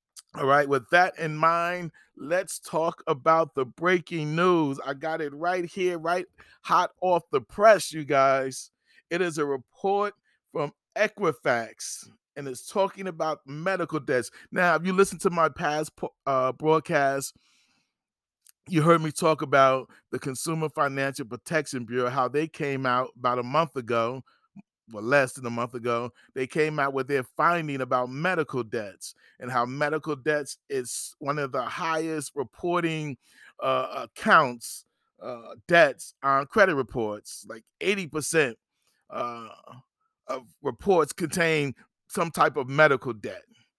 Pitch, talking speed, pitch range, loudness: 155 Hz, 145 wpm, 135-175 Hz, -26 LUFS